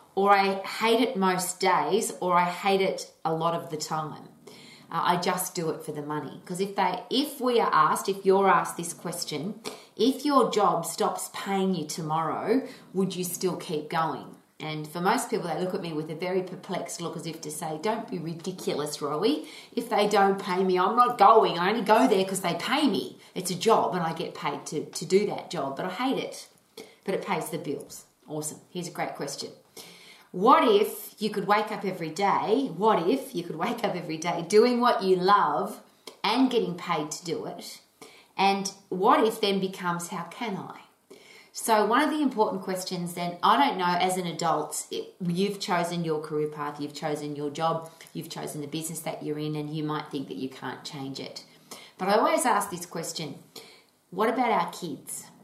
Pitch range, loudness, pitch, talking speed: 160-205 Hz, -27 LUFS, 180 Hz, 210 wpm